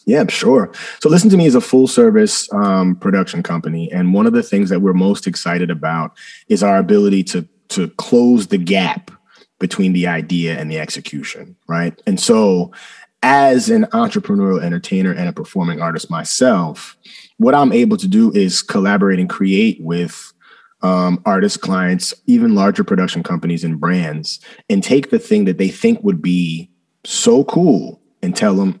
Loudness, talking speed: -15 LUFS, 170 wpm